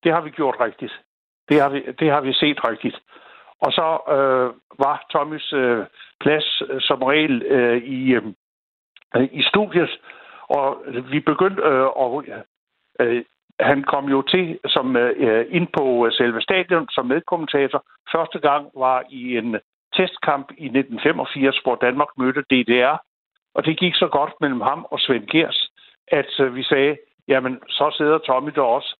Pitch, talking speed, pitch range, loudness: 140 Hz, 160 wpm, 130-155 Hz, -20 LUFS